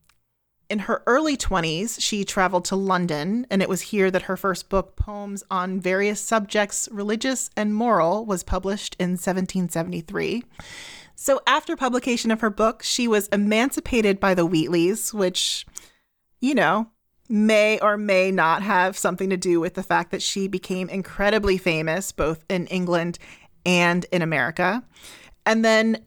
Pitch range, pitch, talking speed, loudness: 180-215 Hz, 195 Hz, 150 wpm, -22 LUFS